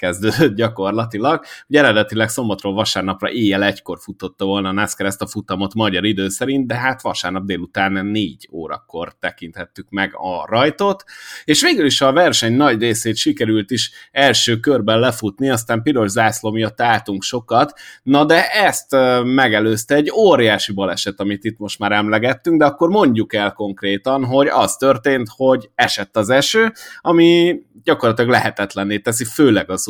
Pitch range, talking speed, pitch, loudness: 100-135 Hz, 155 wpm, 110 Hz, -16 LUFS